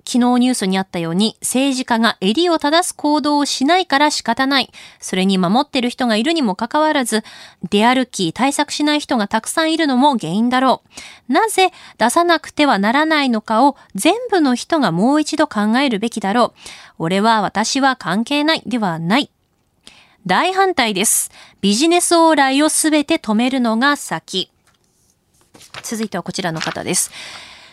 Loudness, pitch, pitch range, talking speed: -16 LUFS, 255 Hz, 215-300 Hz, 320 characters per minute